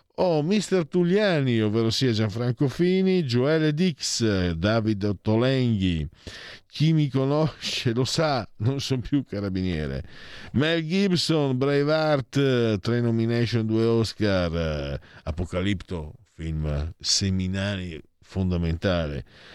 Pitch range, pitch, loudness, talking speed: 95-145 Hz, 115 Hz, -24 LUFS, 105 wpm